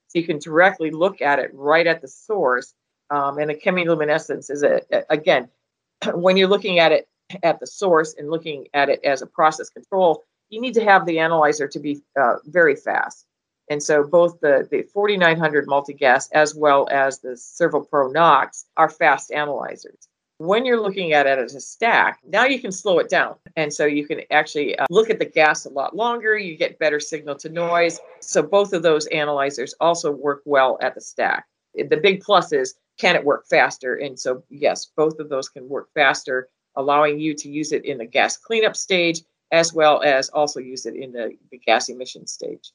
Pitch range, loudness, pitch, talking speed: 145-200 Hz, -19 LUFS, 160 Hz, 205 wpm